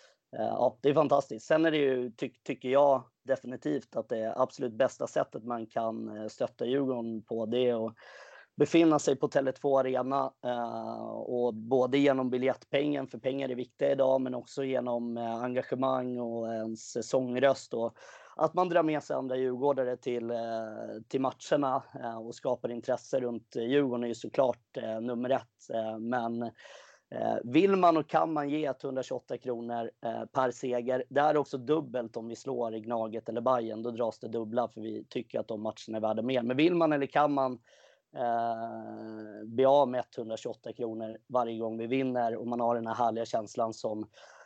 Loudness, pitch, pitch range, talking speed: -31 LUFS, 125 Hz, 115-135 Hz, 185 wpm